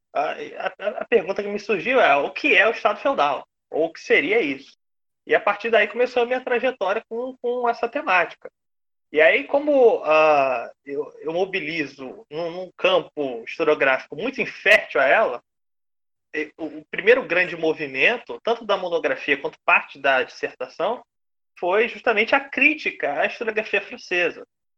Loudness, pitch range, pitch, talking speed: -21 LUFS, 180-265 Hz, 225 Hz, 155 wpm